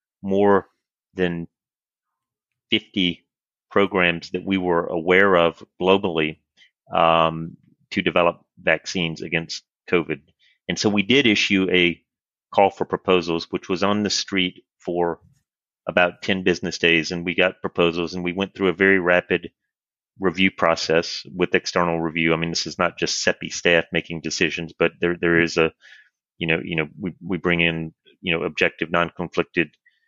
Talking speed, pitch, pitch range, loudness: 160 wpm, 90 Hz, 85-95 Hz, -21 LUFS